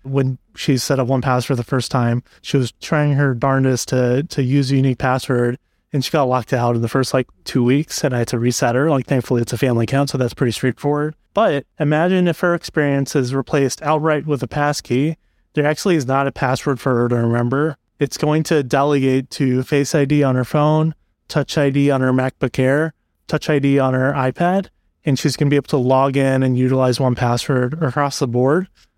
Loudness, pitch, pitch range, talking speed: -18 LUFS, 135 Hz, 130-150 Hz, 220 wpm